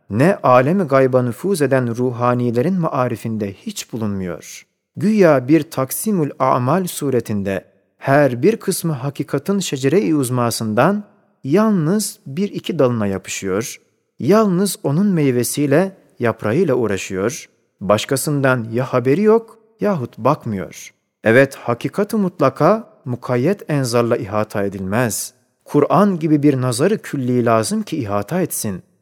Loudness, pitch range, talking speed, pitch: -18 LUFS, 120-185 Hz, 110 wpm, 135 Hz